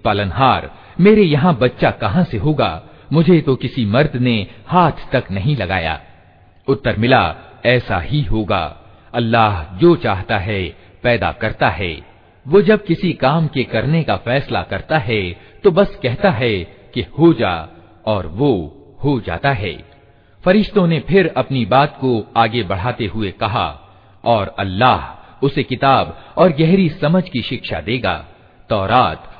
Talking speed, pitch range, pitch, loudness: 145 wpm, 100-150 Hz, 120 Hz, -16 LUFS